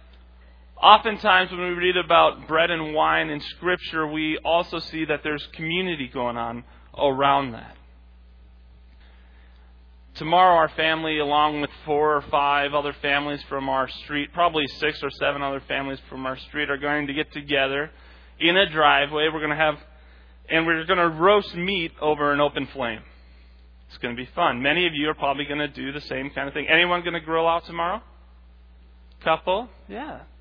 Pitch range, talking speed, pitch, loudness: 115-160 Hz, 180 wpm, 145 Hz, -22 LUFS